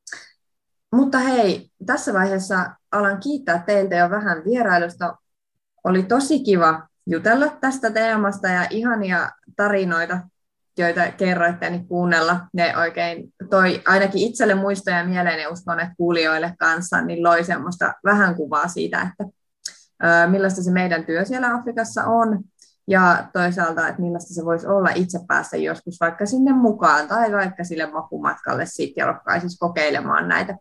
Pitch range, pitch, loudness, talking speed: 170-205 Hz, 180 Hz, -20 LUFS, 140 wpm